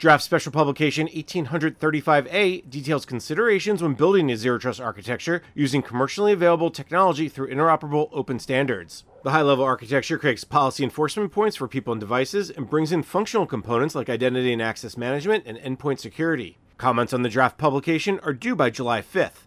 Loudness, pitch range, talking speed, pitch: -23 LUFS, 130-160 Hz, 170 wpm, 145 Hz